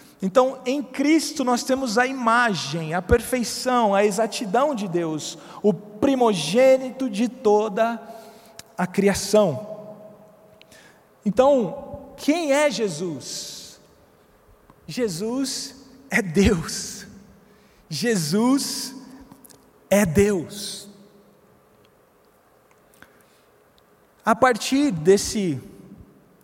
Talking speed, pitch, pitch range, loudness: 75 wpm, 225 Hz, 200-255 Hz, -22 LUFS